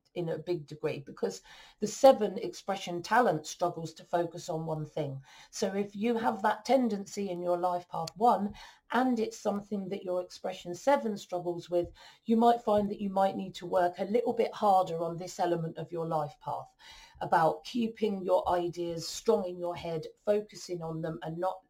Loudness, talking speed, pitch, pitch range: -31 LUFS, 190 wpm, 185 Hz, 175-215 Hz